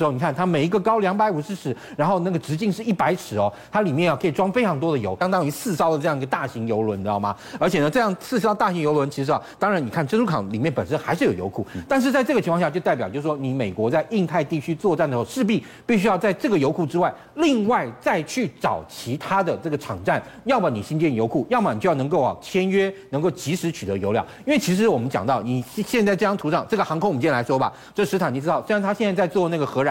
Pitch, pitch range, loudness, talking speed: 170 Hz, 140-205 Hz, -22 LUFS, 405 characters per minute